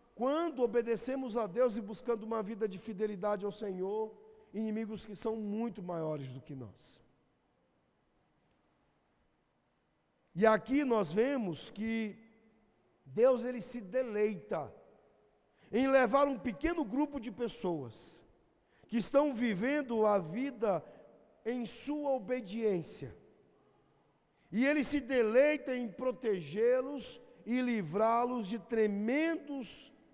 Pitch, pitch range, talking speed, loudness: 230 Hz, 210-255 Hz, 110 wpm, -34 LUFS